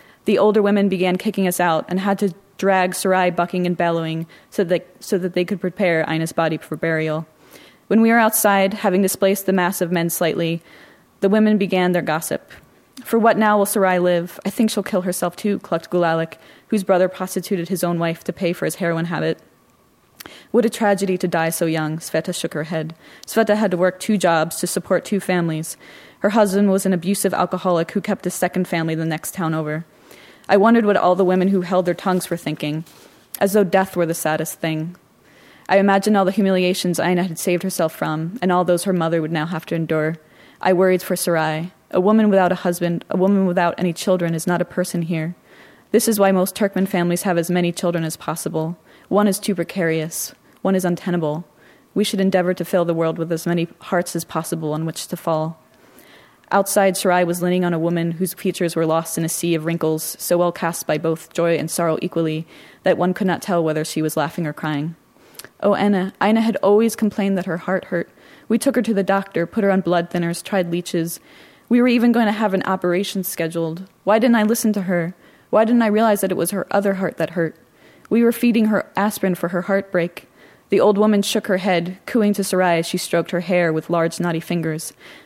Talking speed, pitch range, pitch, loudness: 220 wpm, 165-195 Hz, 180 Hz, -19 LUFS